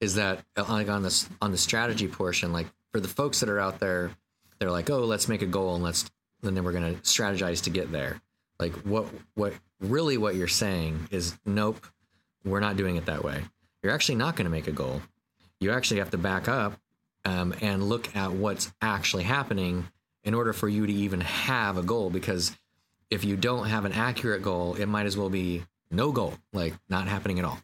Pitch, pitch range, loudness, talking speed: 95 Hz, 90-105 Hz, -28 LUFS, 215 wpm